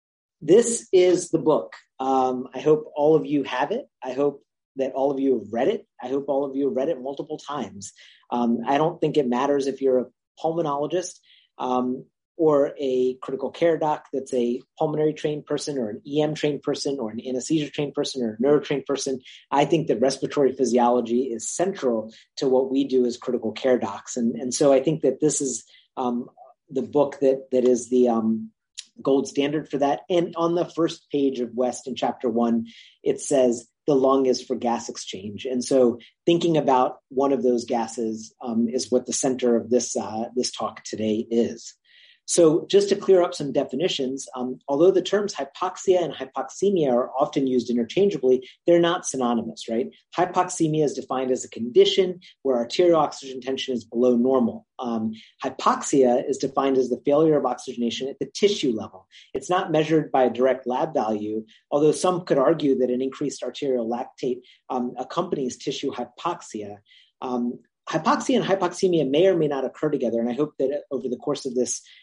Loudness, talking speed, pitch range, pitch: -23 LUFS, 190 wpm, 125-150 Hz, 135 Hz